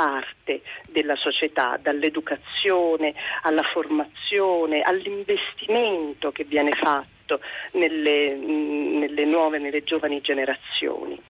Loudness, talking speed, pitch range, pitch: -23 LUFS, 85 wpm, 150-165 Hz, 155 Hz